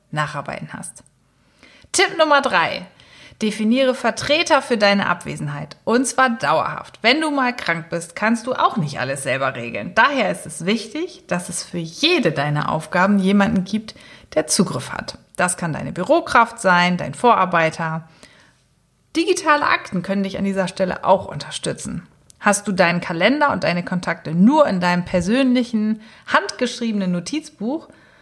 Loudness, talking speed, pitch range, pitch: -19 LUFS, 145 wpm, 175-250 Hz, 200 Hz